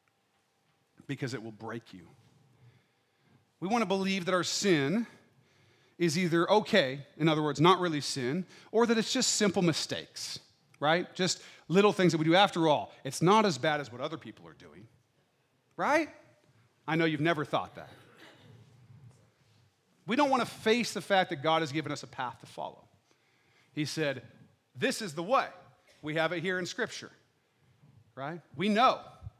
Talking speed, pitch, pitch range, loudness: 170 wpm, 155 Hz, 130-185 Hz, -29 LUFS